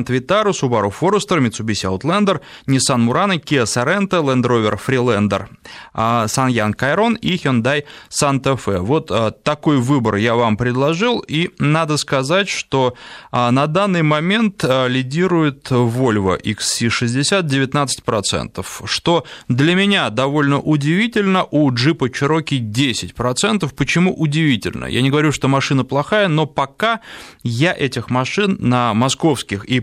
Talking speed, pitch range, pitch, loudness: 120 wpm, 120-165 Hz, 140 Hz, -17 LUFS